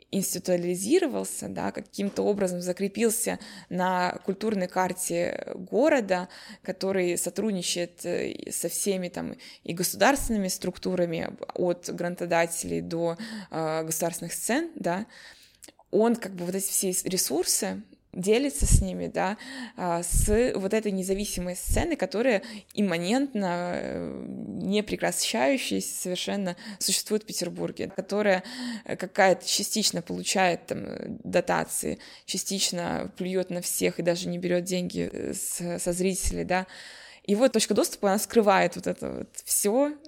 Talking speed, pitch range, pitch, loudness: 110 wpm, 175-215 Hz, 190 Hz, -27 LUFS